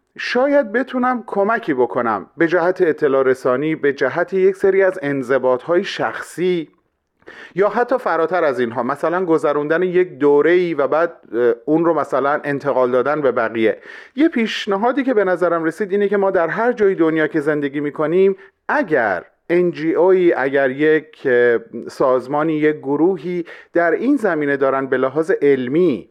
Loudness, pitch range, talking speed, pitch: -17 LUFS, 140-195 Hz, 150 wpm, 165 Hz